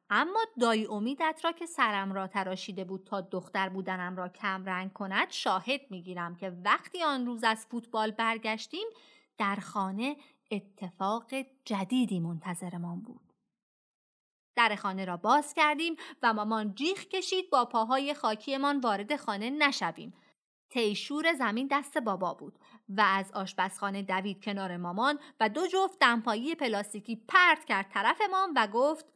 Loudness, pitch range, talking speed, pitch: -31 LUFS, 195-285 Hz, 140 wpm, 225 Hz